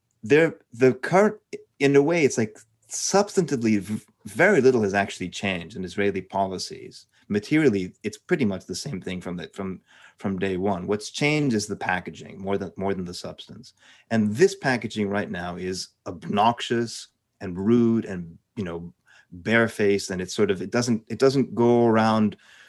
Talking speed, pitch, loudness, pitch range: 170 wpm, 110 Hz, -24 LUFS, 95-125 Hz